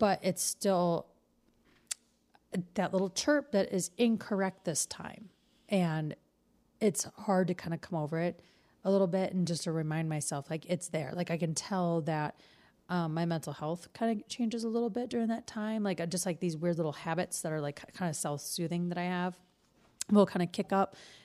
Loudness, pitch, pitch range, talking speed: -33 LUFS, 180 Hz, 165-200 Hz, 200 wpm